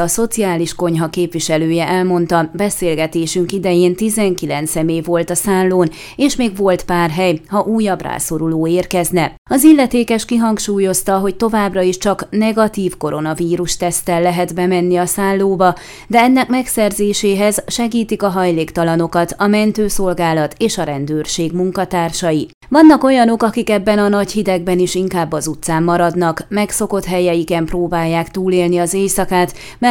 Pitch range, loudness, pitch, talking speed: 170-205 Hz, -15 LUFS, 180 Hz, 130 wpm